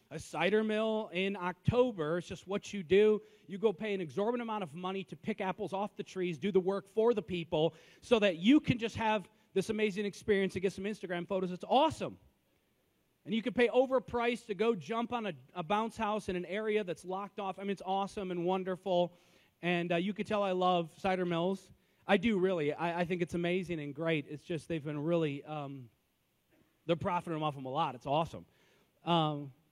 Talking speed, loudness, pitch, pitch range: 210 wpm, -34 LUFS, 190 Hz, 170-210 Hz